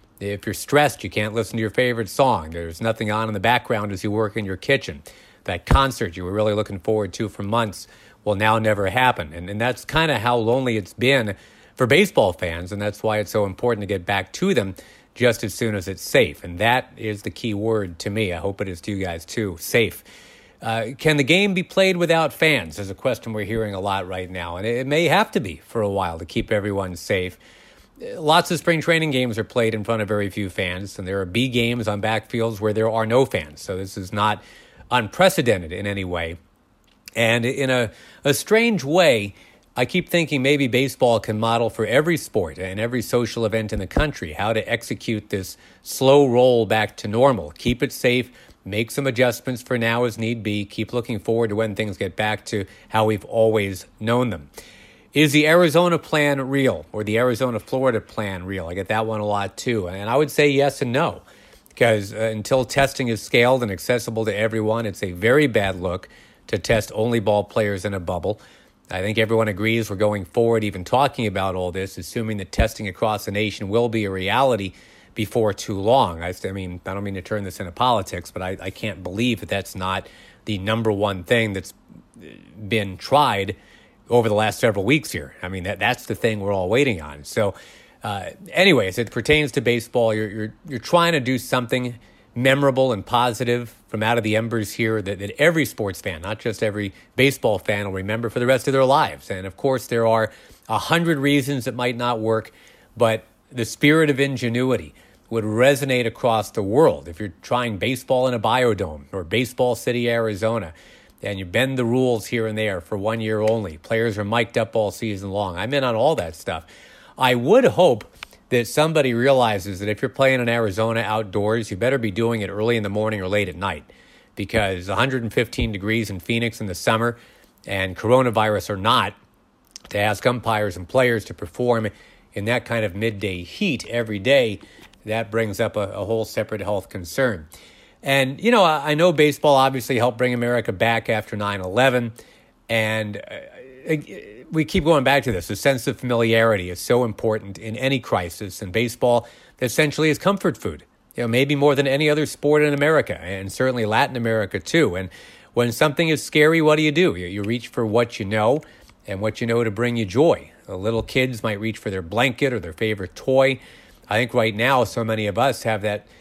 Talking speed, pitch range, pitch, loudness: 210 wpm, 105-125 Hz, 110 Hz, -21 LUFS